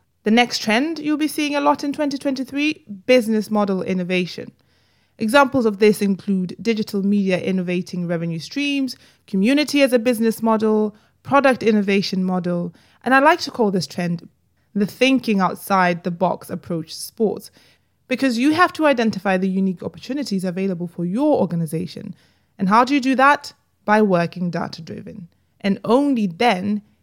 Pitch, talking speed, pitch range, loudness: 215 Hz, 155 wpm, 185-265 Hz, -19 LUFS